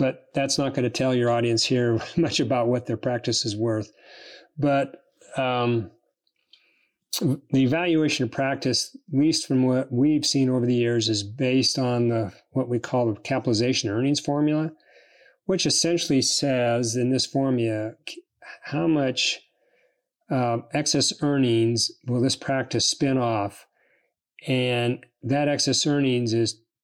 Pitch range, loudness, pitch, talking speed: 120-145 Hz, -23 LUFS, 130 Hz, 140 wpm